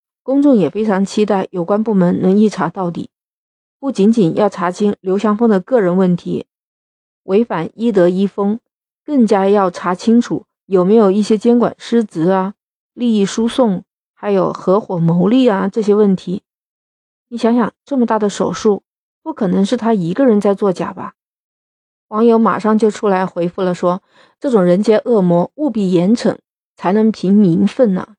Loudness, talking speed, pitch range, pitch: -15 LUFS, 245 characters per minute, 185-230 Hz, 205 Hz